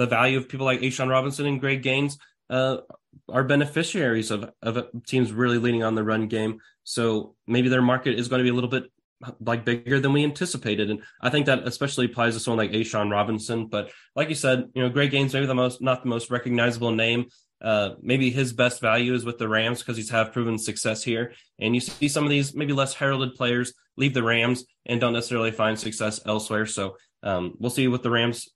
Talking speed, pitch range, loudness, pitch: 225 wpm, 115-130 Hz, -24 LUFS, 120 Hz